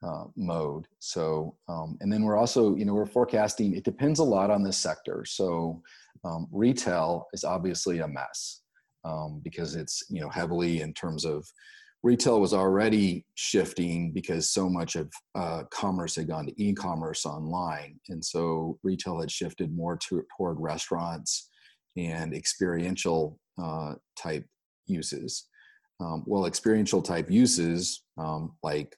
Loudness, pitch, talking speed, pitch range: -29 LUFS, 85 Hz, 150 wpm, 80-105 Hz